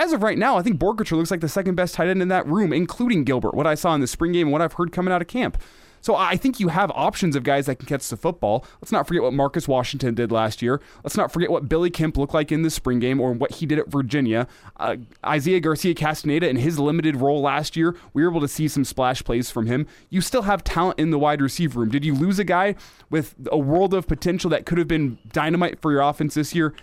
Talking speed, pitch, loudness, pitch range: 275 wpm, 155 Hz, -22 LUFS, 140-175 Hz